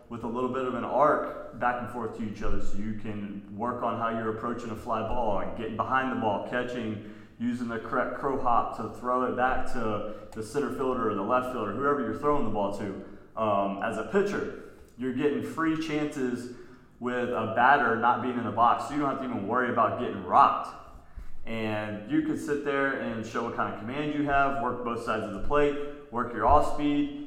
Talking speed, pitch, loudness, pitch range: 225 wpm, 120 Hz, -29 LUFS, 110-135 Hz